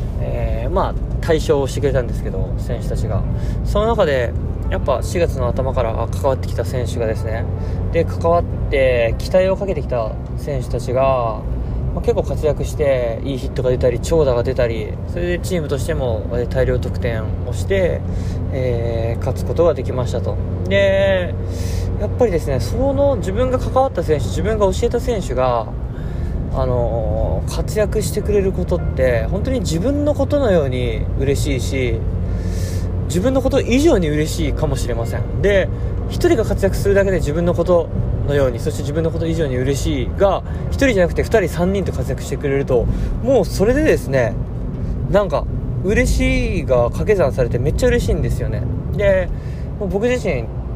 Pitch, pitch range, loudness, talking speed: 100 Hz, 90-120 Hz, -19 LUFS, 330 characters per minute